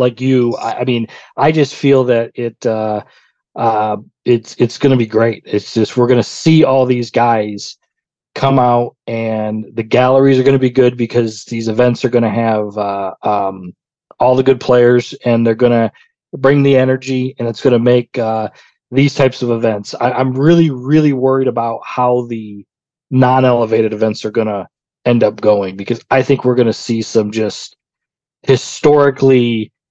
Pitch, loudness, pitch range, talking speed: 120 Hz, -13 LUFS, 110-130 Hz, 170 wpm